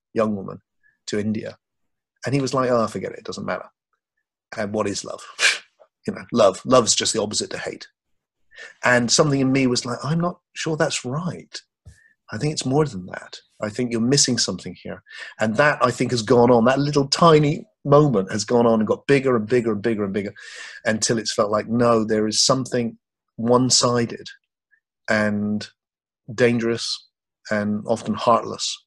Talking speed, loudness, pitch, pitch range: 185 wpm, -20 LUFS, 120 Hz, 110-135 Hz